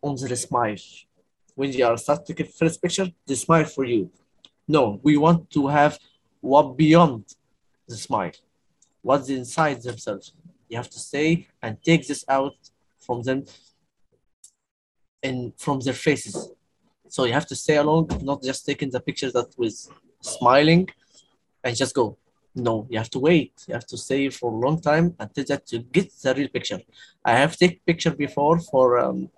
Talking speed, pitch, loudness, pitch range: 175 wpm, 140 Hz, -22 LUFS, 125-155 Hz